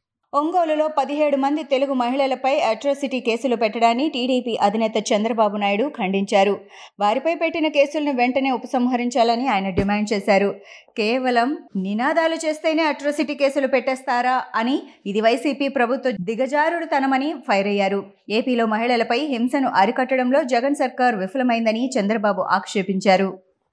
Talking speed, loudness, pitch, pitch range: 110 wpm, -20 LUFS, 250 Hz, 215-280 Hz